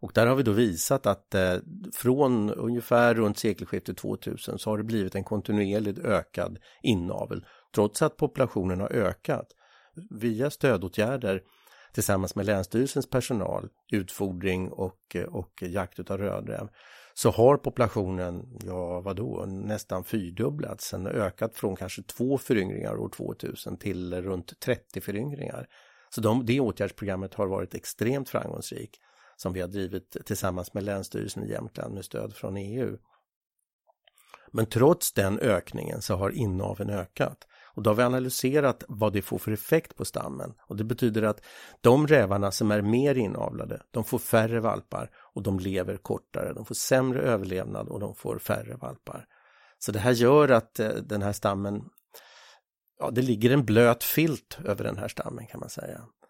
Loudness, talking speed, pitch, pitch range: -28 LUFS, 155 wpm, 105 Hz, 95-125 Hz